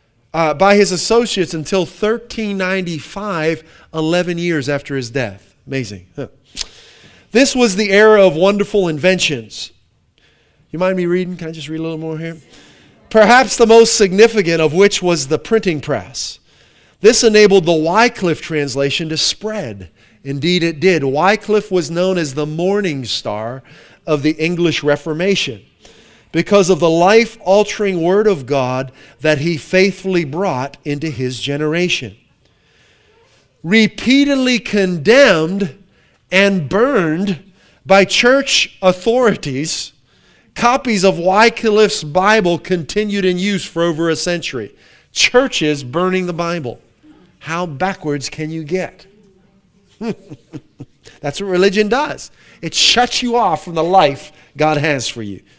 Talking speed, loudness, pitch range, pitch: 130 wpm, -14 LUFS, 150-200 Hz, 175 Hz